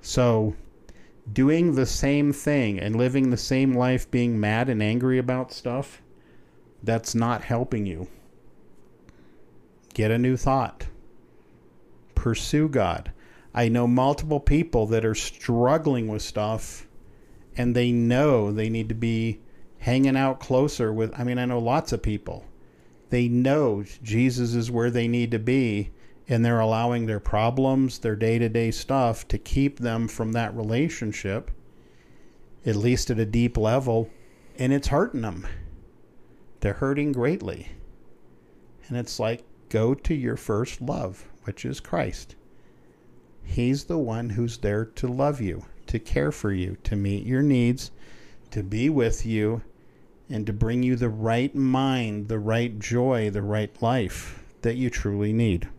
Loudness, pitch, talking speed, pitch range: -25 LUFS, 115 Hz, 150 wpm, 105-130 Hz